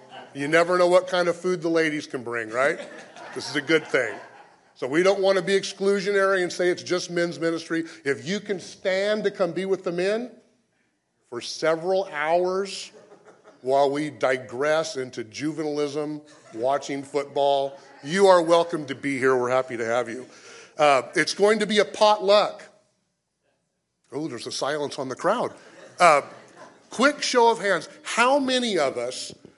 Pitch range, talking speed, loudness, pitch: 145-195 Hz, 170 wpm, -23 LUFS, 170 Hz